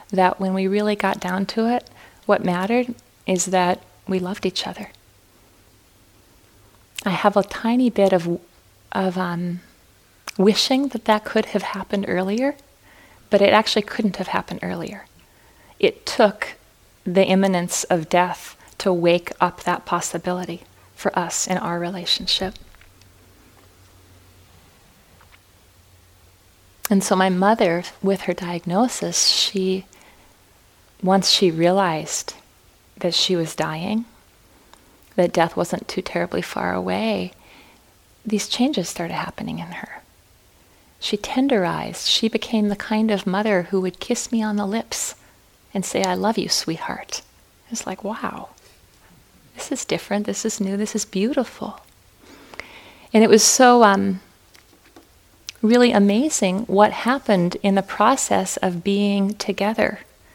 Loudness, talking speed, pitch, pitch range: -20 LUFS, 130 wpm, 190 Hz, 170-210 Hz